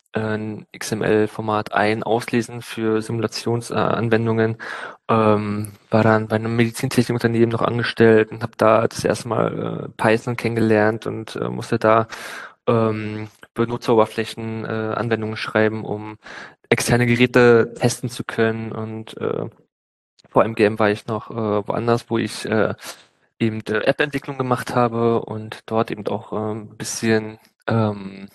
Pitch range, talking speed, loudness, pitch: 110-115 Hz, 135 wpm, -20 LUFS, 110 Hz